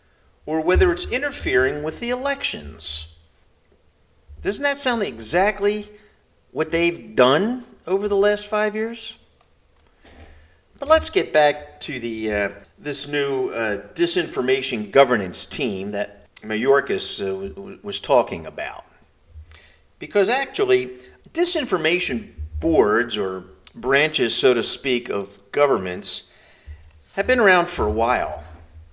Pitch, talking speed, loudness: 145 Hz, 120 wpm, -20 LUFS